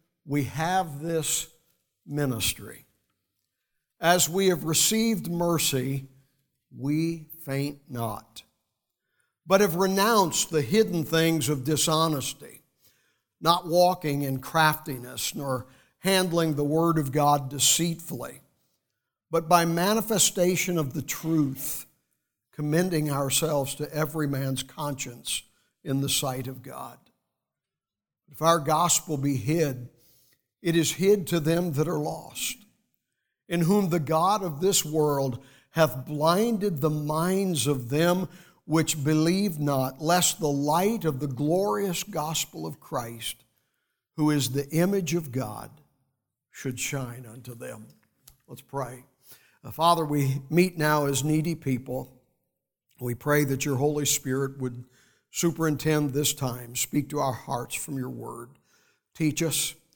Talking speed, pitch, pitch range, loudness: 125 wpm, 155 Hz, 135-170 Hz, -26 LUFS